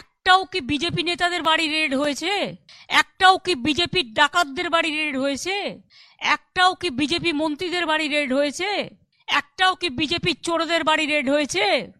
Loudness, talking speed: -21 LUFS, 140 wpm